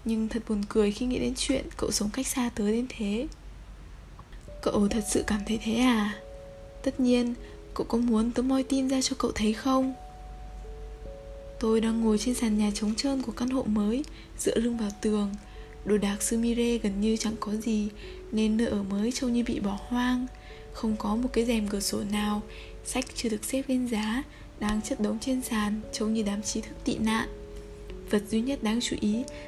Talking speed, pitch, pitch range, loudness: 205 wpm, 225 Hz, 210-245 Hz, -28 LUFS